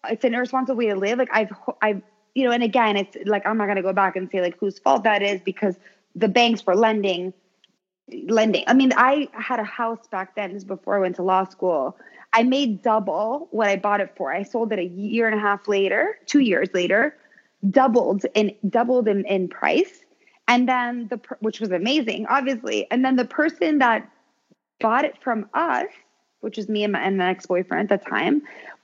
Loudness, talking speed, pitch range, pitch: -22 LUFS, 215 wpm, 200-250 Hz, 220 Hz